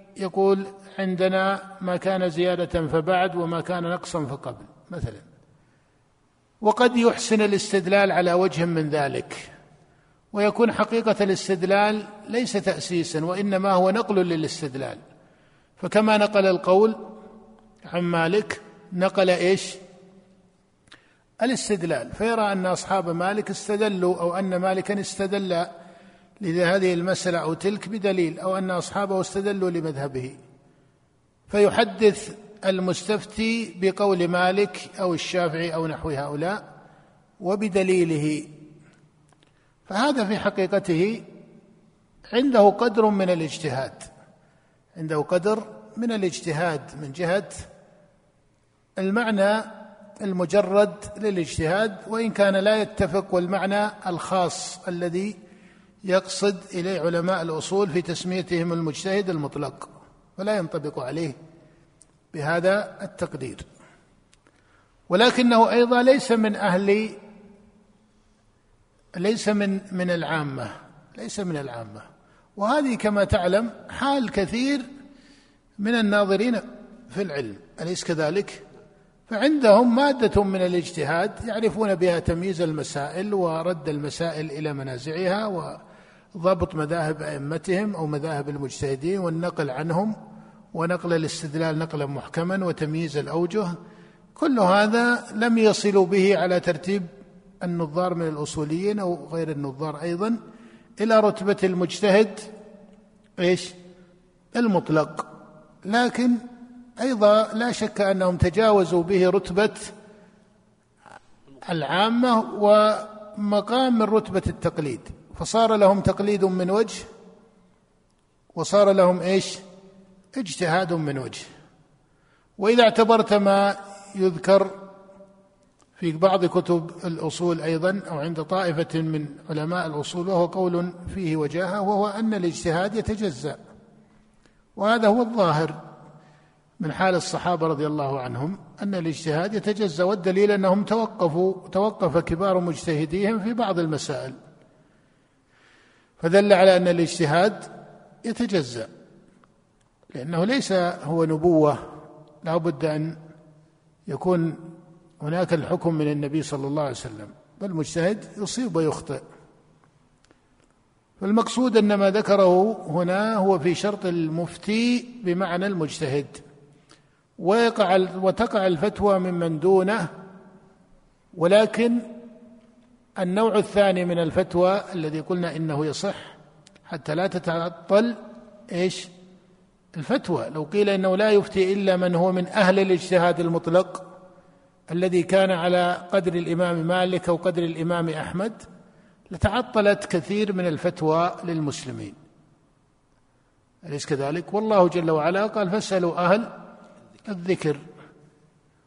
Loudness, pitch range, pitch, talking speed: -23 LUFS, 165-205 Hz, 185 Hz, 100 wpm